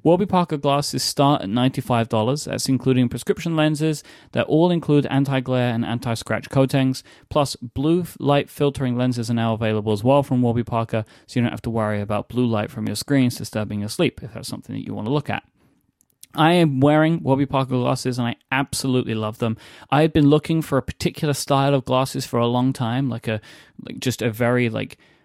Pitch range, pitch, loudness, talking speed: 115-140 Hz, 130 Hz, -21 LUFS, 200 wpm